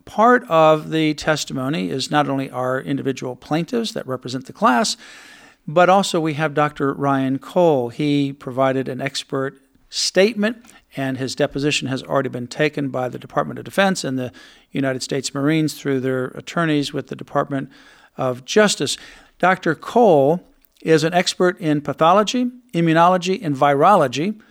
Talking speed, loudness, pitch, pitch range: 150 wpm, -19 LUFS, 145 Hz, 135-175 Hz